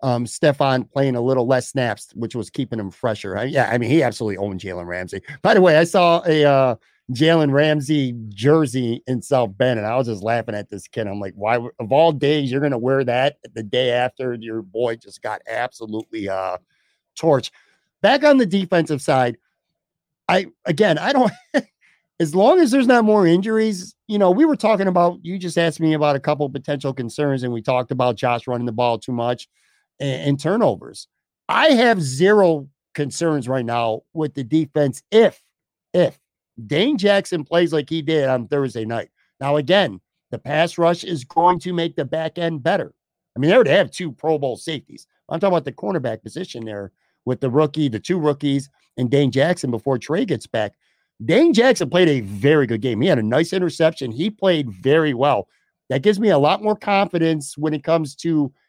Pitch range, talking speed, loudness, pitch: 125-170 Hz, 200 wpm, -19 LUFS, 145 Hz